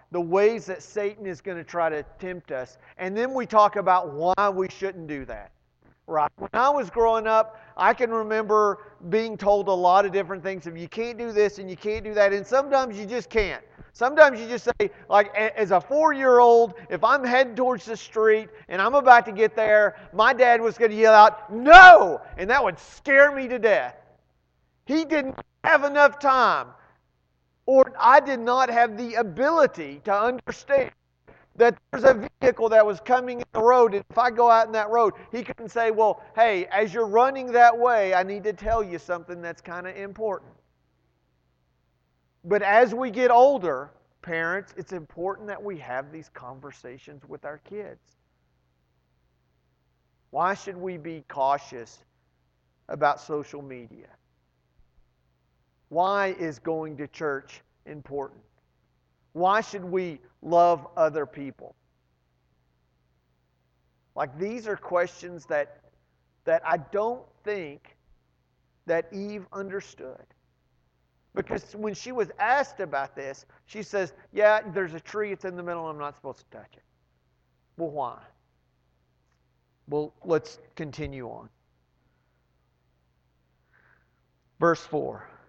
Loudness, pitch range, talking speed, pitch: -21 LUFS, 130-225 Hz, 155 wpm, 185 Hz